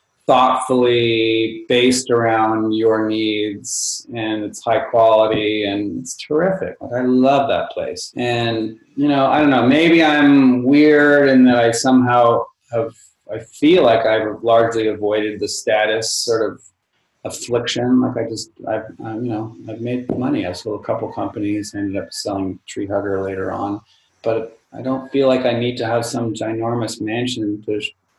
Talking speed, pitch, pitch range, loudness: 170 wpm, 115 Hz, 110-125 Hz, -17 LUFS